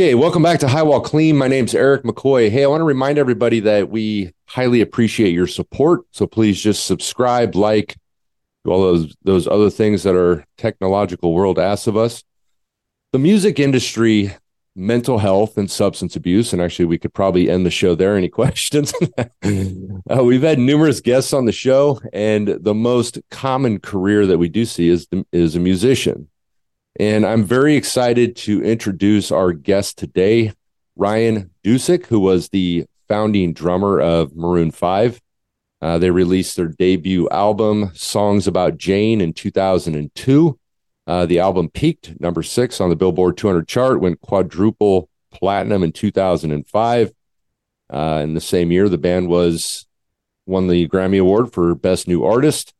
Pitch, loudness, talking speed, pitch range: 100 Hz, -16 LUFS, 165 wpm, 90-120 Hz